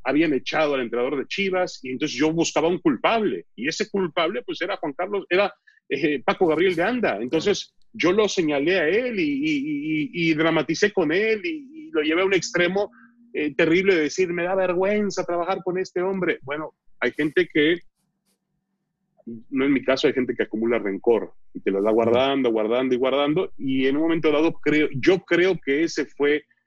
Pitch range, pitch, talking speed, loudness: 145-195 Hz, 175 Hz, 200 wpm, -22 LUFS